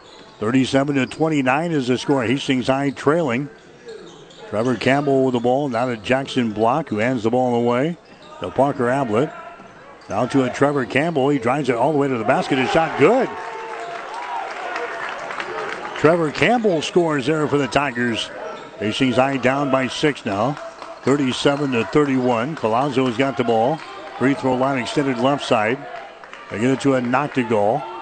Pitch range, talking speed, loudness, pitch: 125-145 Hz, 165 wpm, -20 LUFS, 135 Hz